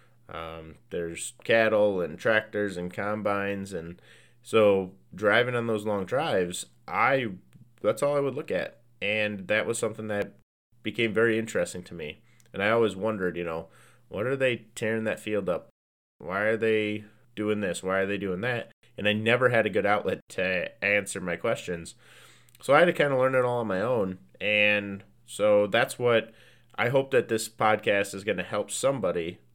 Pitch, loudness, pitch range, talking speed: 105 Hz, -27 LUFS, 95-115 Hz, 185 wpm